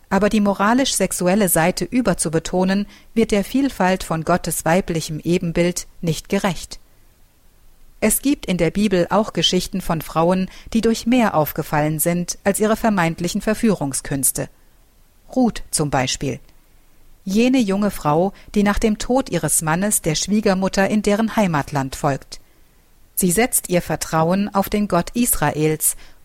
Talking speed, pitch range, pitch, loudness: 135 wpm, 160-210 Hz, 185 Hz, -19 LUFS